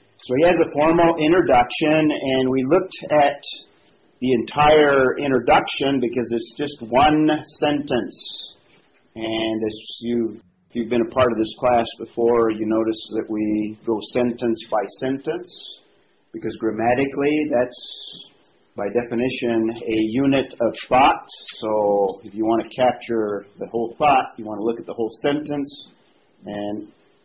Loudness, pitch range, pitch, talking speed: -21 LUFS, 110-145 Hz, 120 Hz, 145 wpm